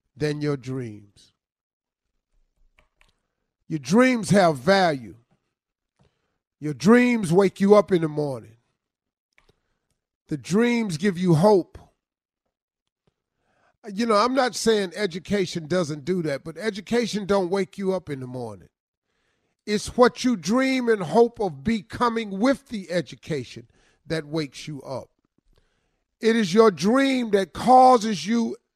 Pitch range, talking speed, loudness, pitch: 150-225 Hz, 125 wpm, -22 LUFS, 190 Hz